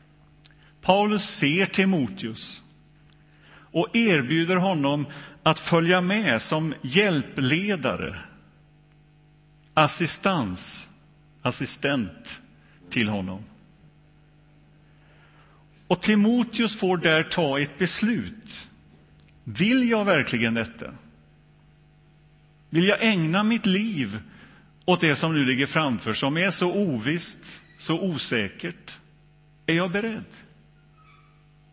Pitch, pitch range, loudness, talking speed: 155 Hz, 145-185 Hz, -23 LUFS, 85 wpm